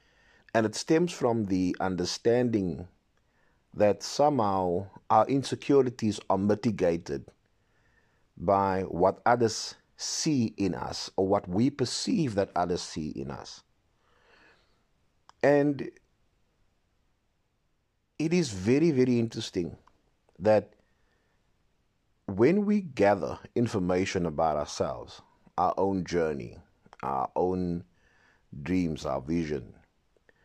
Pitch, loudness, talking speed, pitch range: 100 Hz, -28 LUFS, 95 wpm, 90-120 Hz